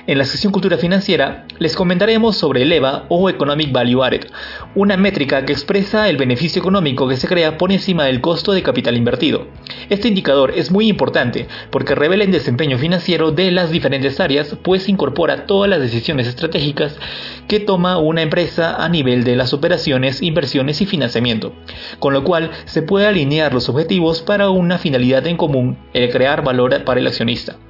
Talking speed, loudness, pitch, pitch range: 180 wpm, -15 LUFS, 165 Hz, 135-190 Hz